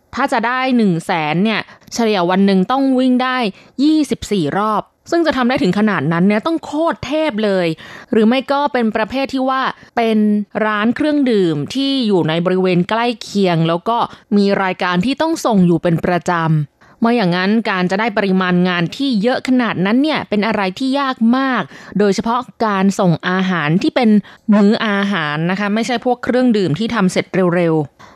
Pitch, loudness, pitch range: 215 Hz, -16 LUFS, 185-250 Hz